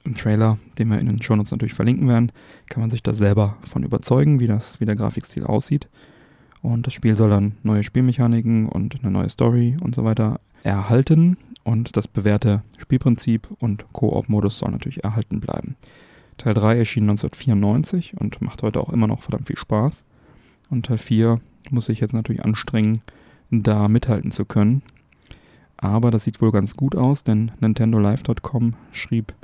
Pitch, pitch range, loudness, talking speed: 115 Hz, 105-125 Hz, -20 LUFS, 170 wpm